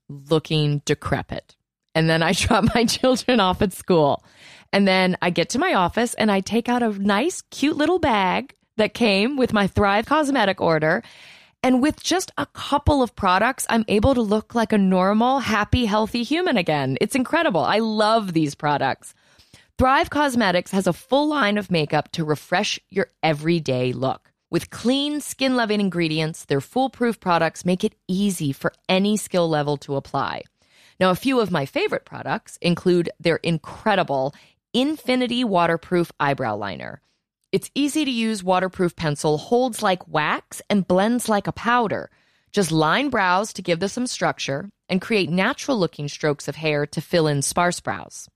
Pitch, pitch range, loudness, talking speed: 195 Hz, 165-235 Hz, -21 LUFS, 170 wpm